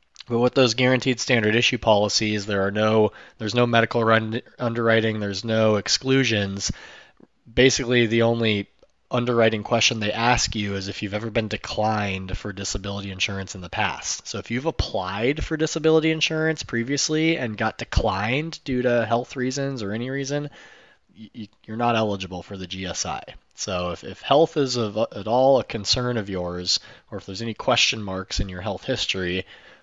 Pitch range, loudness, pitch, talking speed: 100-125 Hz, -23 LUFS, 110 Hz, 170 wpm